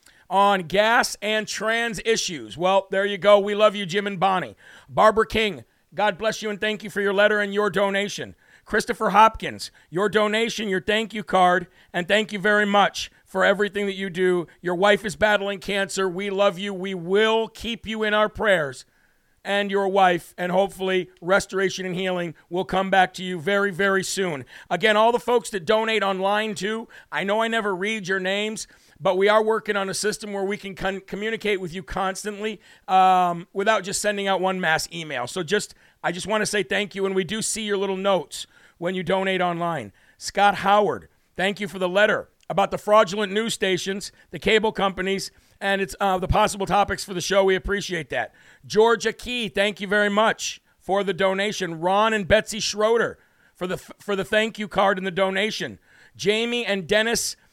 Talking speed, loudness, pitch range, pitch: 200 wpm, -22 LUFS, 190-210 Hz, 200 Hz